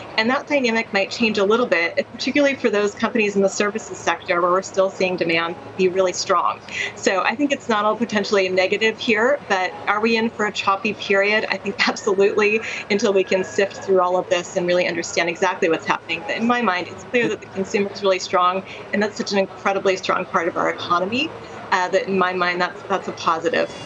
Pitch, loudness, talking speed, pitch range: 195 Hz, -20 LUFS, 225 wpm, 185-220 Hz